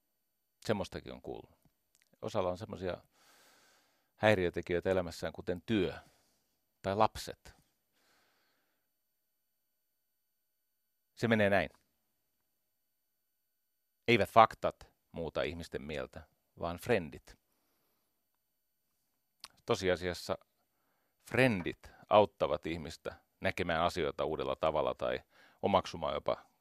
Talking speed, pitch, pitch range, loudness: 75 wpm, 105 Hz, 90-120 Hz, -34 LUFS